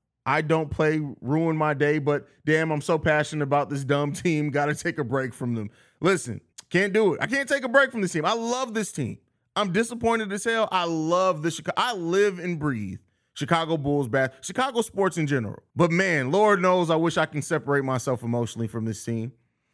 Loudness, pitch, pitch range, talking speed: -25 LUFS, 155 Hz, 135-185 Hz, 215 wpm